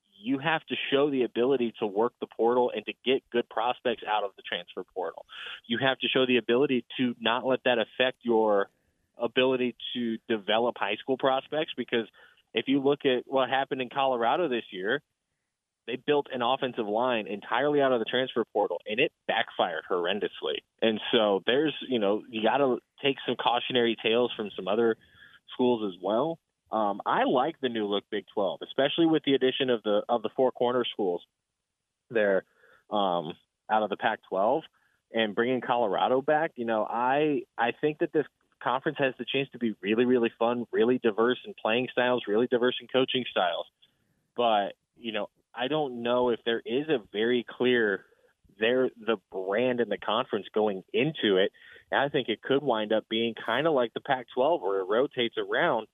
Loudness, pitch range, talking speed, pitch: -28 LUFS, 115-135 Hz, 190 wpm, 125 Hz